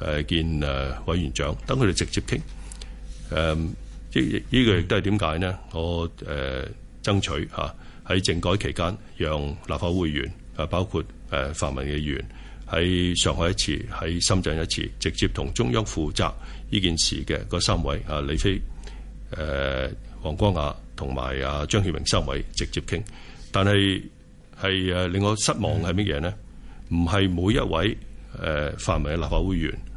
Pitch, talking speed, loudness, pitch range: 85 Hz, 240 characters per minute, -25 LUFS, 75-95 Hz